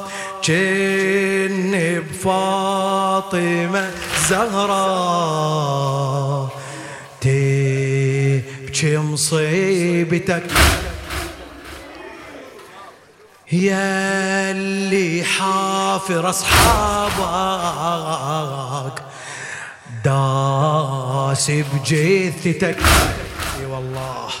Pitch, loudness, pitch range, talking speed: 170 Hz, -18 LUFS, 135-190 Hz, 35 wpm